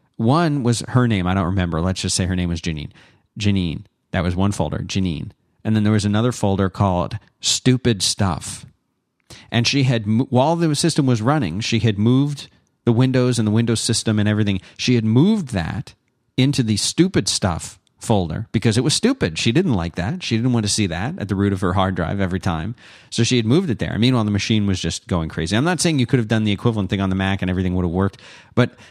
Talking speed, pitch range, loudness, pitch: 235 wpm, 95-125 Hz, -19 LUFS, 110 Hz